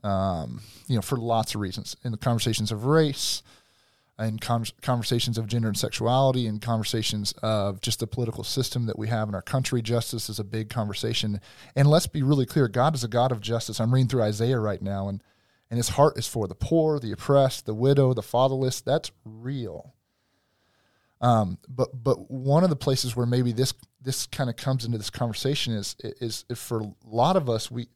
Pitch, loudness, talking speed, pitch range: 120 Hz, -26 LUFS, 205 wpm, 110-130 Hz